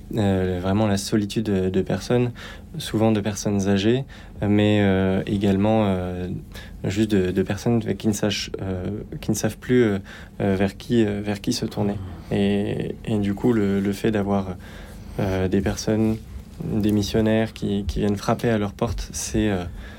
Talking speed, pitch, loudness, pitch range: 175 wpm, 100 Hz, -23 LUFS, 95-110 Hz